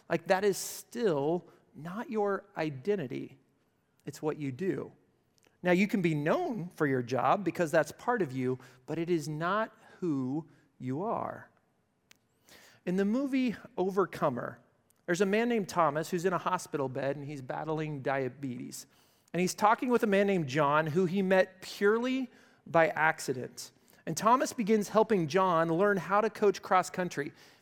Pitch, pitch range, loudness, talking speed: 180 Hz, 155-205 Hz, -31 LUFS, 160 wpm